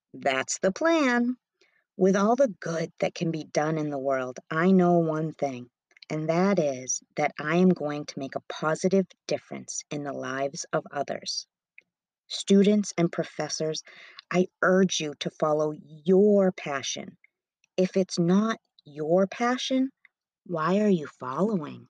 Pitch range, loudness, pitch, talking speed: 150-195 Hz, -26 LUFS, 170 Hz, 150 wpm